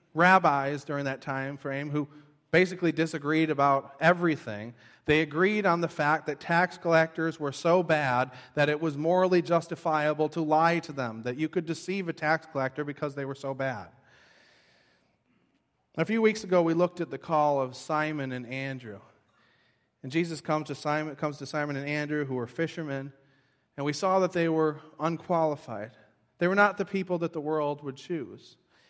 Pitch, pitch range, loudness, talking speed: 150 Hz, 135-165 Hz, -28 LUFS, 175 wpm